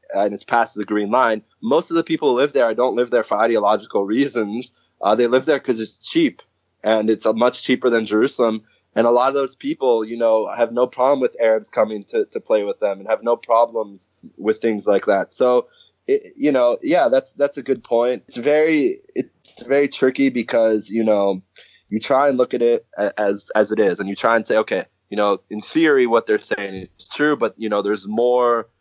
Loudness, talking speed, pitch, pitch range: -19 LUFS, 225 wpm, 120 Hz, 110-140 Hz